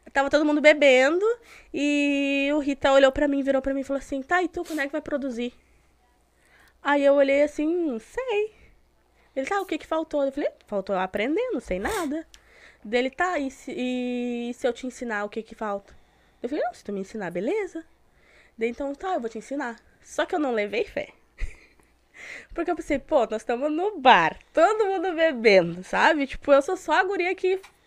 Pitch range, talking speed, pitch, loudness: 245-325 Hz, 205 wpm, 285 Hz, -24 LUFS